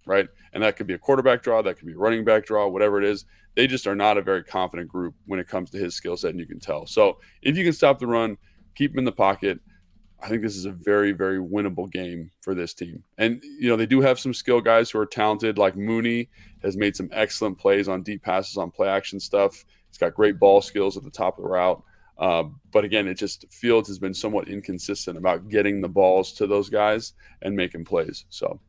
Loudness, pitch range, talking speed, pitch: -23 LUFS, 95-115 Hz, 250 wpm, 100 Hz